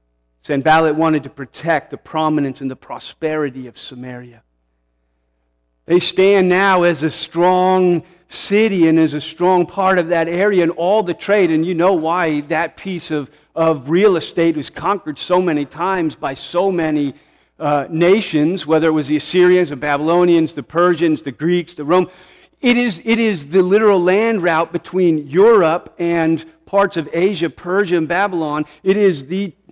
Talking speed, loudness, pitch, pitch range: 170 wpm, -16 LUFS, 165 Hz, 150-185 Hz